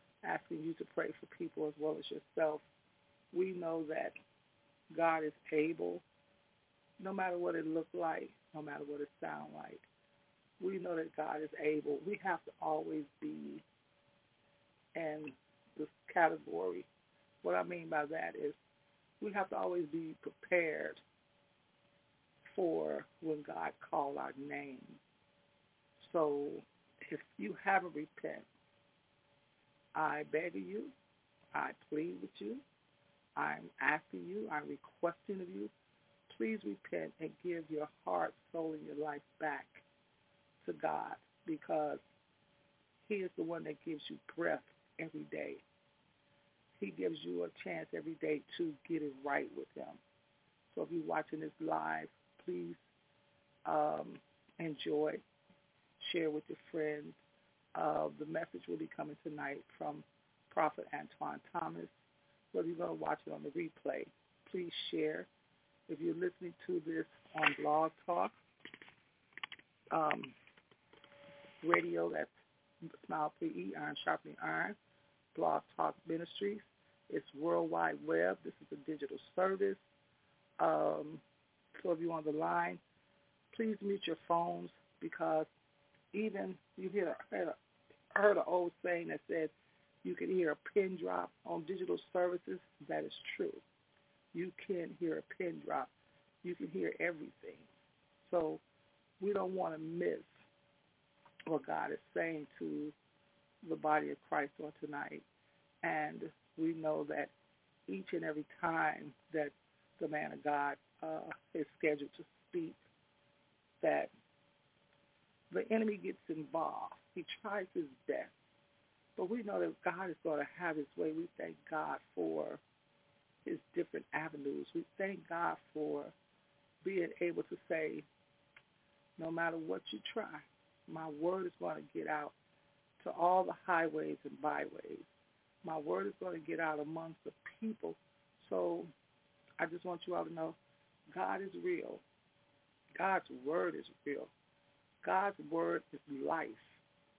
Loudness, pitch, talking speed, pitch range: -40 LUFS, 160 Hz, 140 wpm, 145-185 Hz